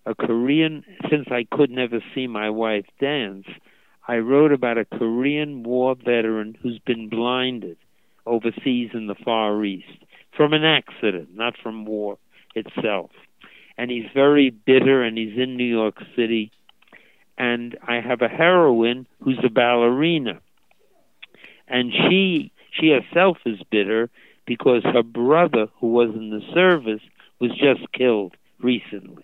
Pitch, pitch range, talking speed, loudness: 120 Hz, 115-135 Hz, 140 wpm, -21 LUFS